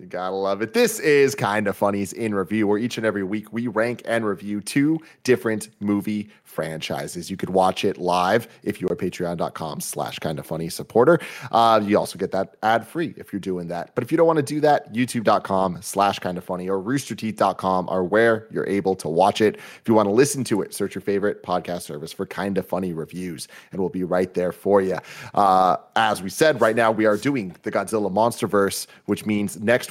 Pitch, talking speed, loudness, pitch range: 100 Hz, 215 wpm, -22 LUFS, 95-115 Hz